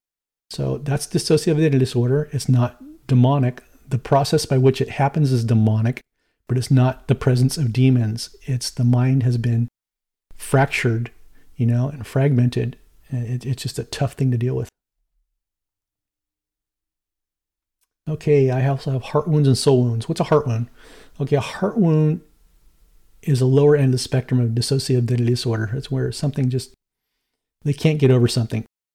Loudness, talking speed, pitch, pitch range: -20 LUFS, 160 wpm, 130 Hz, 120-140 Hz